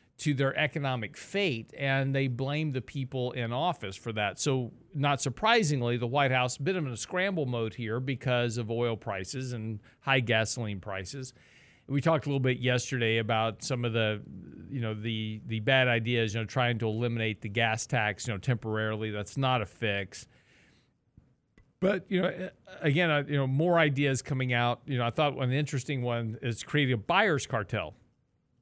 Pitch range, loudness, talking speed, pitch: 115-140 Hz, -30 LUFS, 185 wpm, 125 Hz